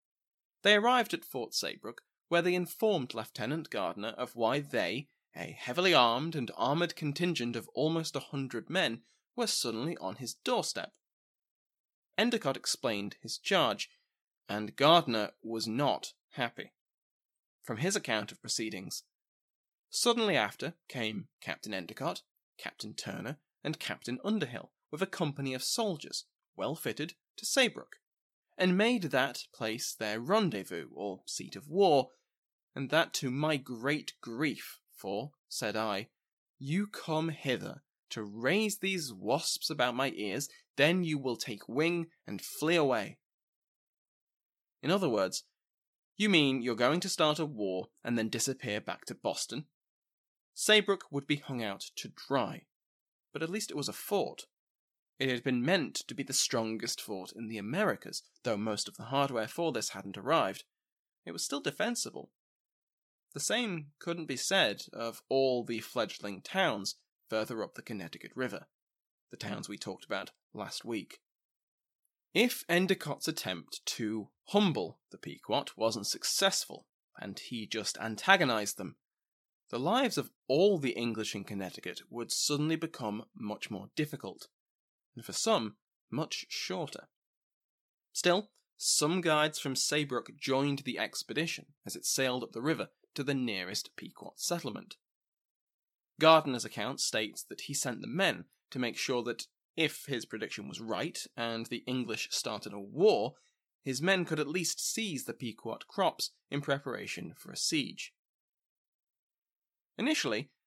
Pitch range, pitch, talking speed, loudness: 115-170 Hz, 140 Hz, 145 wpm, -33 LUFS